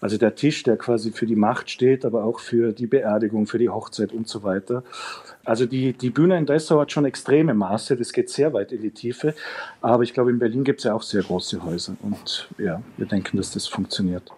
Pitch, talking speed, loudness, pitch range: 120 Hz, 235 wpm, -22 LUFS, 110-140 Hz